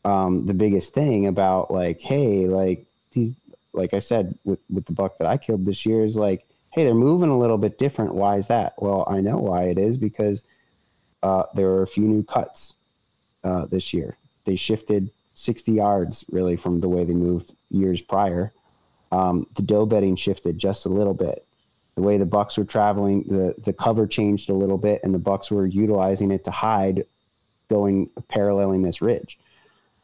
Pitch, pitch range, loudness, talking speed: 100 Hz, 95-105 Hz, -22 LUFS, 190 wpm